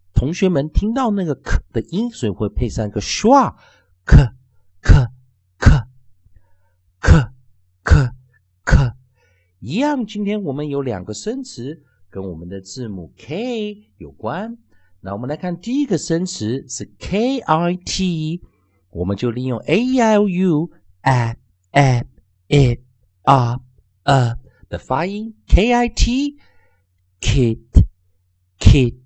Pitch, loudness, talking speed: 125 Hz, -18 LUFS, 180 characters per minute